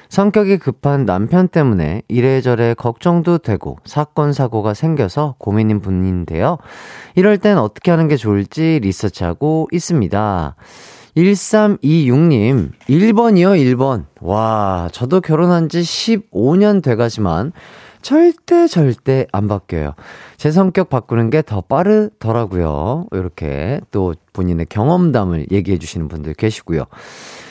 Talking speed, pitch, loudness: 255 characters per minute, 130 Hz, -15 LUFS